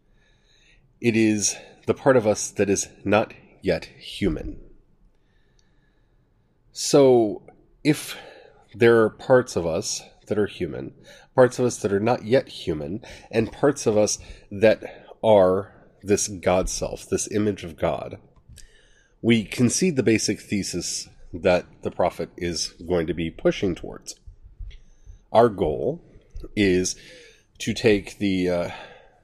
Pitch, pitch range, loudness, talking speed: 105 Hz, 90-120 Hz, -23 LUFS, 130 wpm